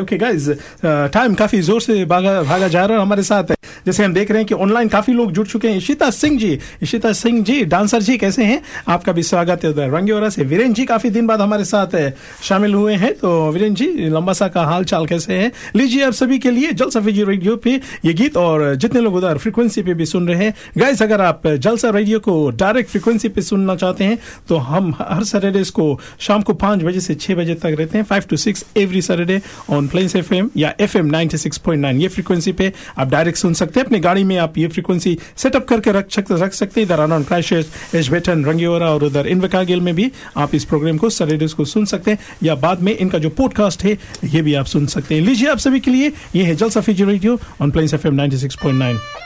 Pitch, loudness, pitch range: 195 Hz, -16 LUFS, 165-220 Hz